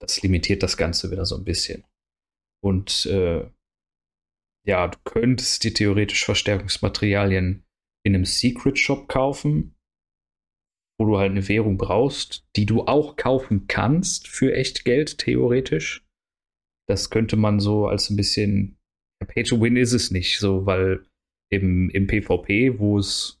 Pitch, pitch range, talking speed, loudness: 100 Hz, 95-115 Hz, 140 wpm, -22 LUFS